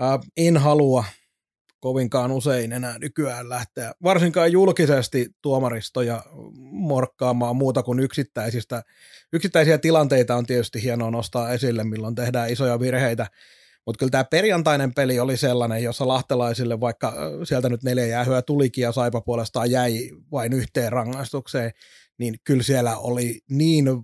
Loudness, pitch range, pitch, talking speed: -22 LUFS, 120-140 Hz, 125 Hz, 130 wpm